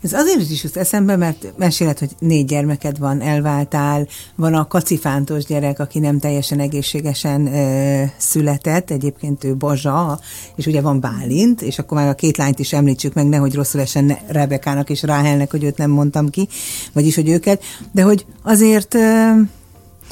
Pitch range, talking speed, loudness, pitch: 140-165 Hz, 165 wpm, -16 LUFS, 145 Hz